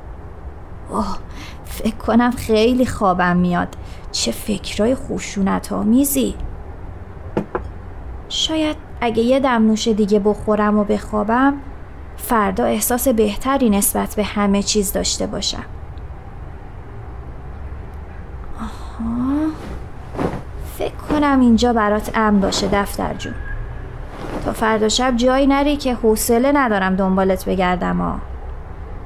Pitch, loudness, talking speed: 210 Hz, -18 LUFS, 100 wpm